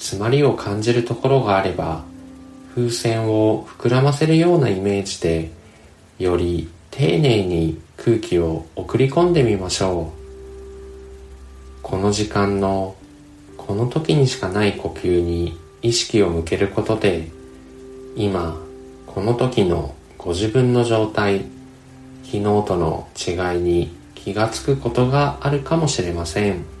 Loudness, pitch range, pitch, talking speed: -20 LUFS, 85-120 Hz, 100 Hz, 240 characters per minute